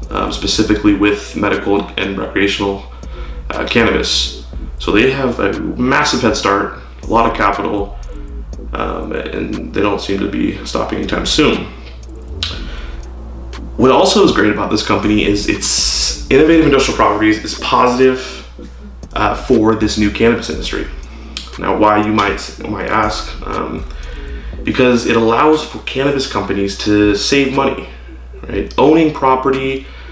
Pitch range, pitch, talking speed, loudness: 65-110 Hz, 95 Hz, 135 wpm, -14 LUFS